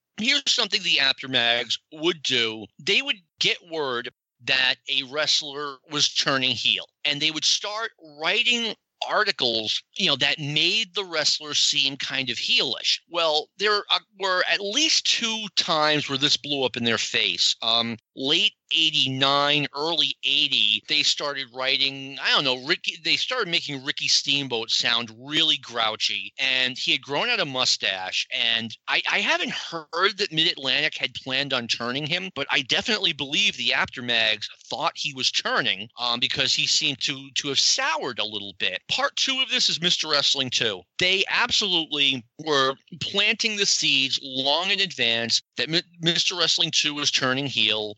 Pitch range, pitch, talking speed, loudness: 130-170 Hz, 145 Hz, 165 wpm, -22 LUFS